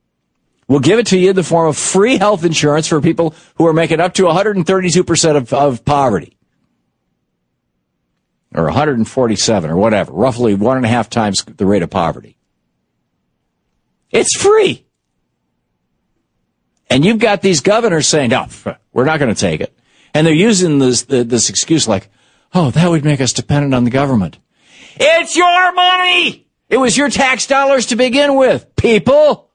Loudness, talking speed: -12 LUFS, 160 wpm